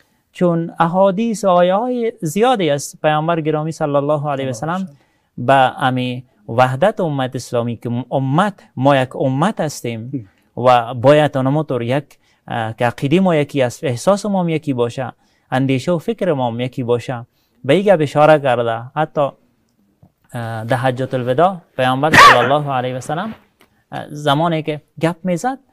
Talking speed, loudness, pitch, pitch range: 150 wpm, -16 LUFS, 145 Hz, 125-170 Hz